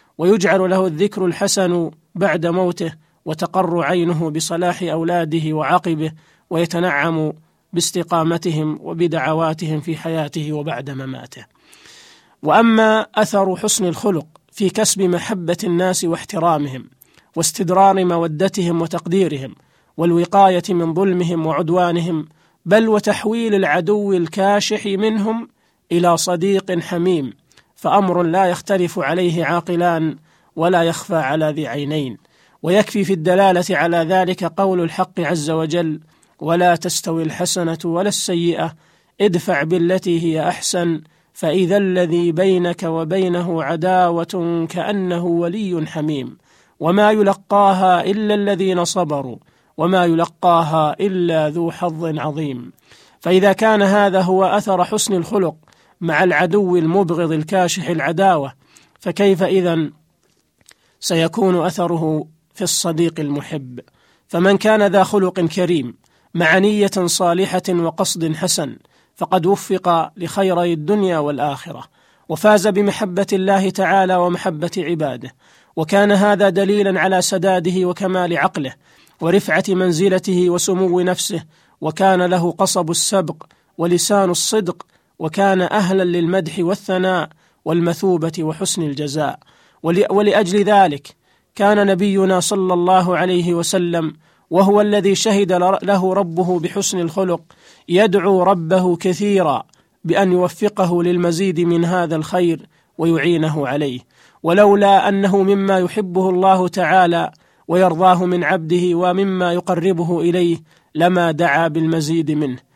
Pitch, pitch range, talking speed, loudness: 180 Hz, 165-190 Hz, 105 wpm, -17 LUFS